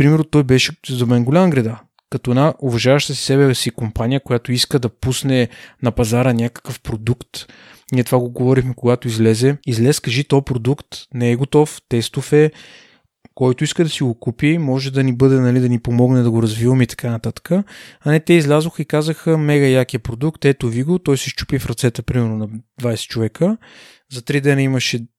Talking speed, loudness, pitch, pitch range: 195 wpm, -17 LUFS, 130 Hz, 120-145 Hz